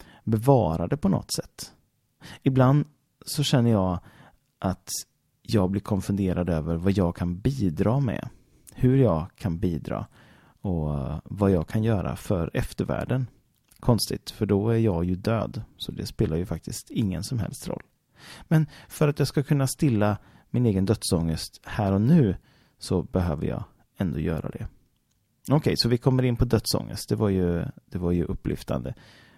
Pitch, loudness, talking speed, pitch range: 105 Hz, -26 LUFS, 160 wpm, 90-125 Hz